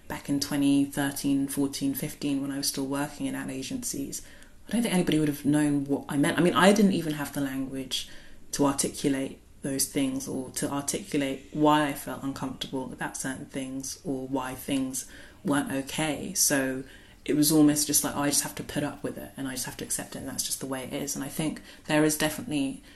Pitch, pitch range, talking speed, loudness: 140 Hz, 135-150 Hz, 220 wpm, -28 LUFS